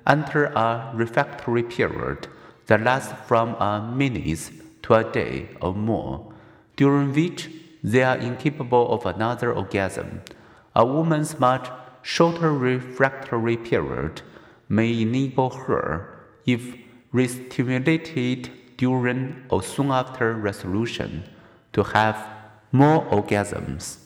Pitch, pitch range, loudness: 125 Hz, 110-135 Hz, -23 LUFS